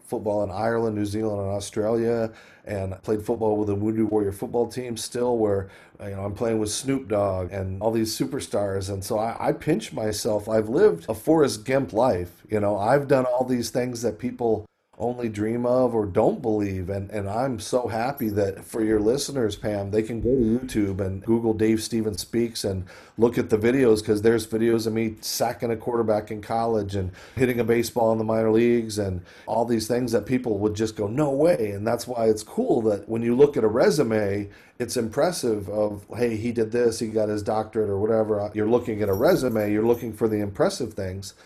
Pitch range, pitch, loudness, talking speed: 105-120 Hz, 110 Hz, -24 LUFS, 210 wpm